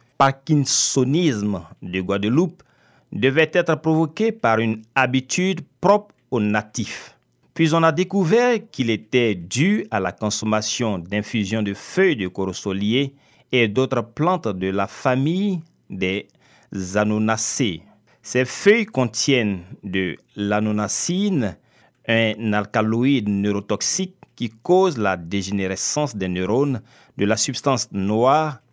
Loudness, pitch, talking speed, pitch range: -21 LUFS, 120 Hz, 115 wpm, 105-155 Hz